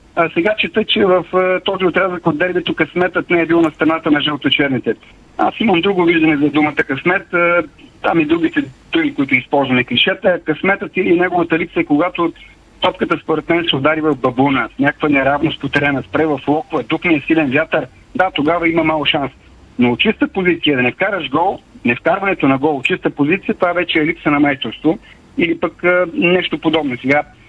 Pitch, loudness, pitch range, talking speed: 165 Hz, -15 LUFS, 150-180 Hz, 195 wpm